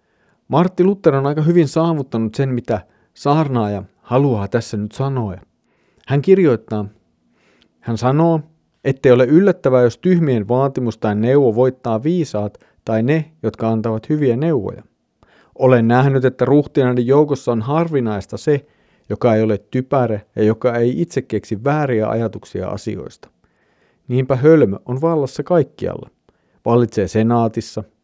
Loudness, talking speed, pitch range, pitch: -17 LUFS, 130 wpm, 110-150 Hz, 125 Hz